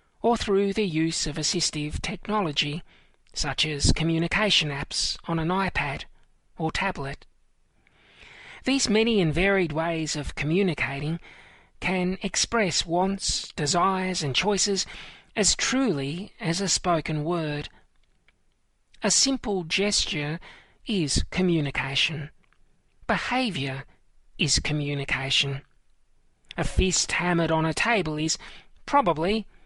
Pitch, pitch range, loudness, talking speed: 170 Hz, 150-195 Hz, -25 LUFS, 105 wpm